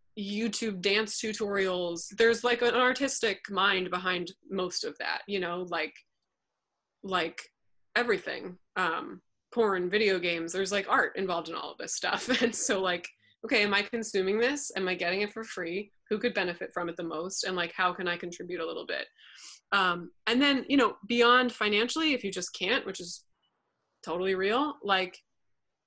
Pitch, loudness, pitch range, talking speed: 195 Hz, -29 LUFS, 180-225 Hz, 175 wpm